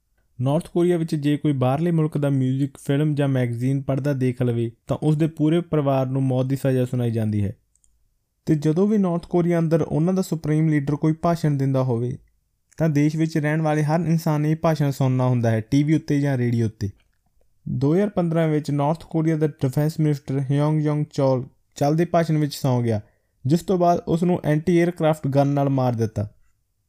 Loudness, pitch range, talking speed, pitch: -22 LUFS, 130-160 Hz, 185 wpm, 145 Hz